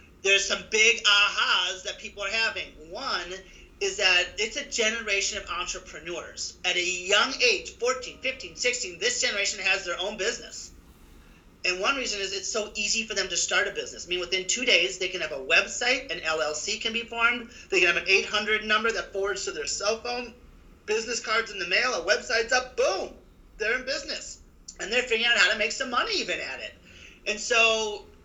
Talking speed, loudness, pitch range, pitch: 200 wpm, -25 LUFS, 195-255 Hz, 220 Hz